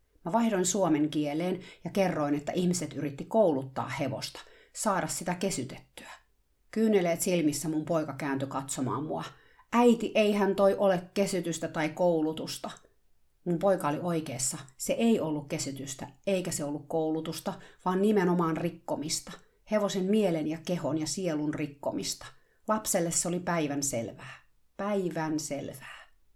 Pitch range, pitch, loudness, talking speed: 150-195 Hz, 170 Hz, -30 LUFS, 130 wpm